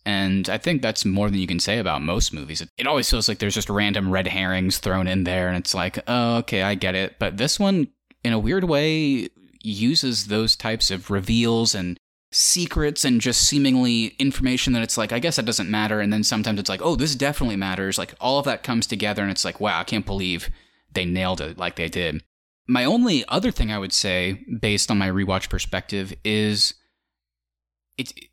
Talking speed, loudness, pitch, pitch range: 215 wpm, -22 LUFS, 105 Hz, 95-120 Hz